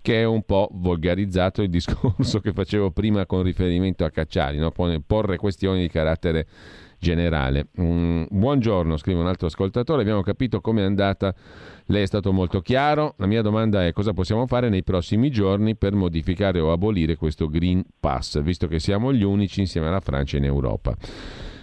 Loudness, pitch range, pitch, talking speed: -22 LUFS, 85-105 Hz, 95 Hz, 170 wpm